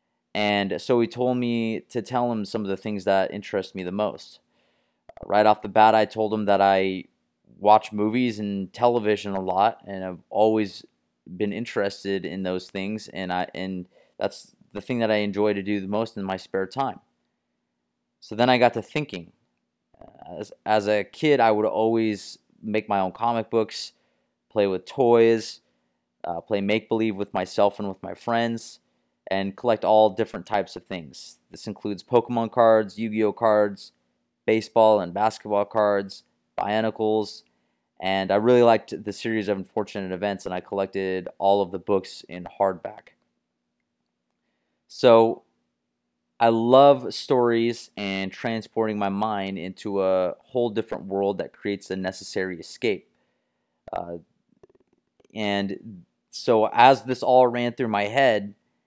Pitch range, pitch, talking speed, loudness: 95-115 Hz, 105 Hz, 155 wpm, -23 LUFS